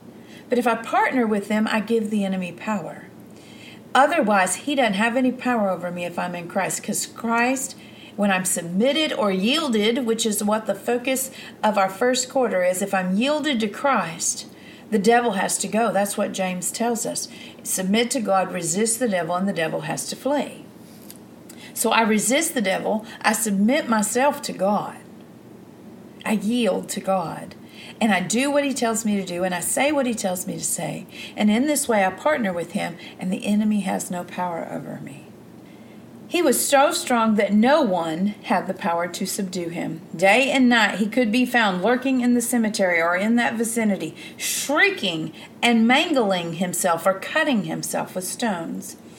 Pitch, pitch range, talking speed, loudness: 220 Hz, 190-250 Hz, 185 wpm, -21 LUFS